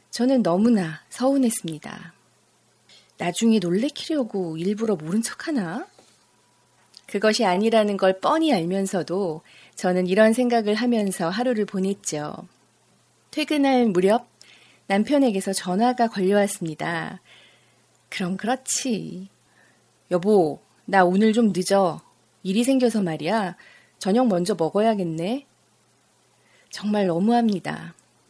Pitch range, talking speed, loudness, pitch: 185-235 Hz, 240 characters per minute, -22 LUFS, 205 Hz